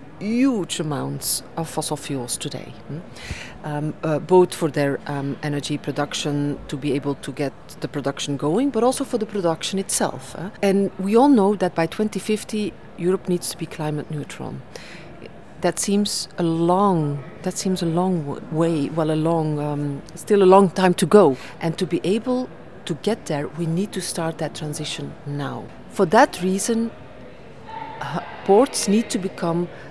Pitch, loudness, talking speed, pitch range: 170 Hz, -22 LUFS, 175 wpm, 150-195 Hz